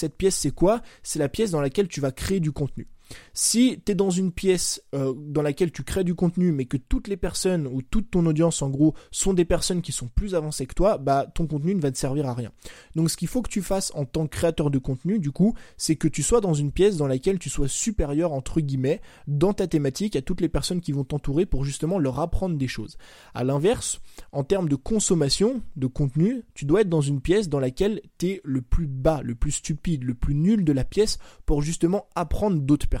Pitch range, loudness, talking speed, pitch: 140-190 Hz, -25 LUFS, 245 wpm, 160 Hz